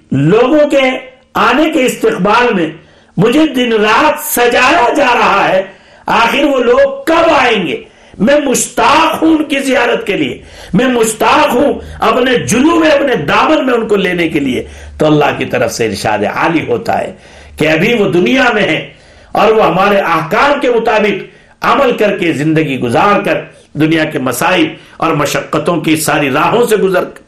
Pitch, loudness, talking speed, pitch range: 225 Hz, -10 LUFS, 170 wpm, 175-260 Hz